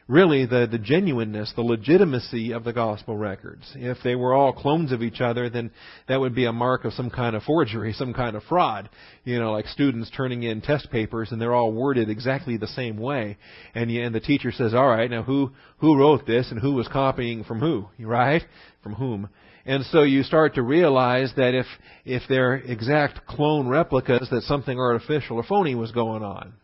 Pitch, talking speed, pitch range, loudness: 125 Hz, 205 wpm, 115-135 Hz, -23 LUFS